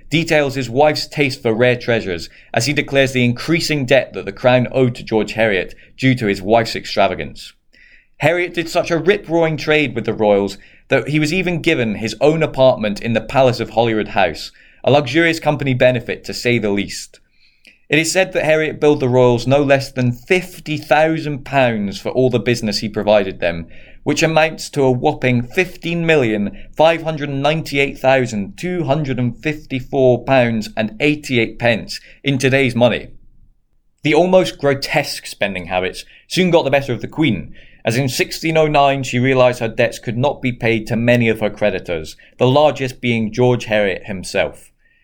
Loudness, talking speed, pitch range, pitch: -16 LUFS, 185 wpm, 115-150 Hz, 130 Hz